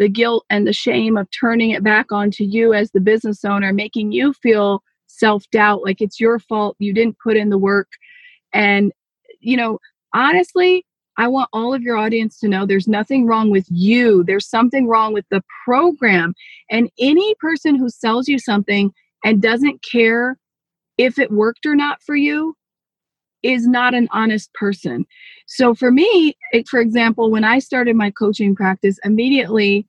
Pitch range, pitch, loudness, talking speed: 205-250 Hz, 225 Hz, -16 LUFS, 175 wpm